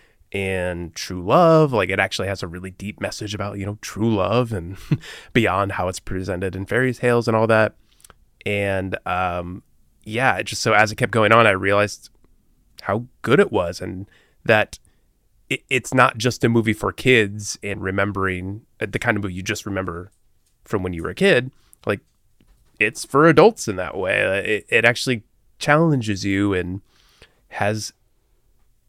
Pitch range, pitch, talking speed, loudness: 95-115 Hz, 105 Hz, 170 wpm, -20 LUFS